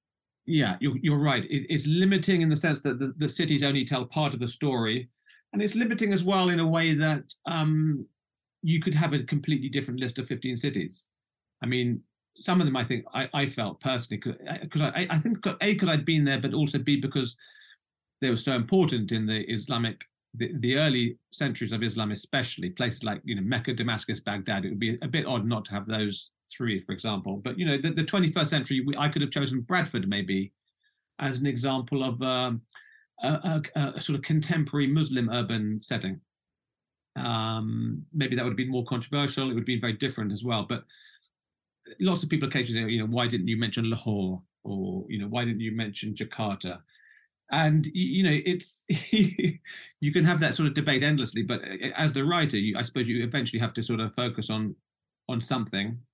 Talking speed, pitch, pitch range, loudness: 205 wpm, 135 Hz, 115-155 Hz, -28 LUFS